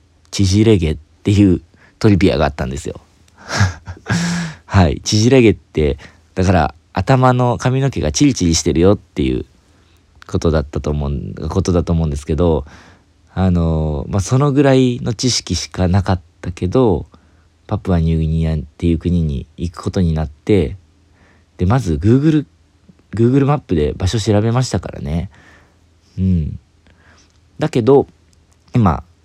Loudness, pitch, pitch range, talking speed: -16 LUFS, 90 Hz, 80-105 Hz, 285 characters per minute